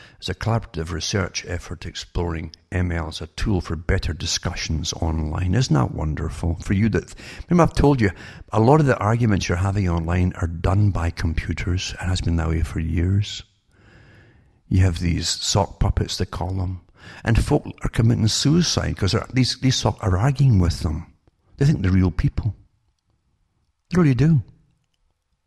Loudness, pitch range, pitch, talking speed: -22 LUFS, 85-110 Hz, 95 Hz, 175 wpm